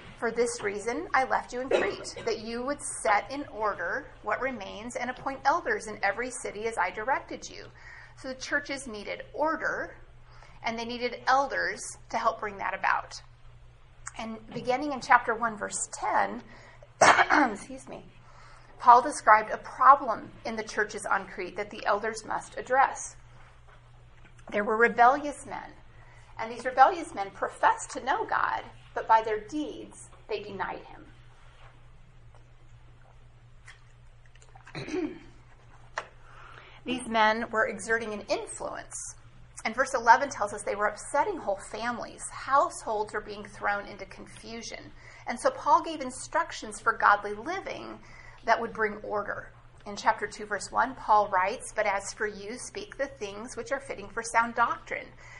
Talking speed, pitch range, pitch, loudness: 145 wpm, 205-265 Hz, 225 Hz, -28 LUFS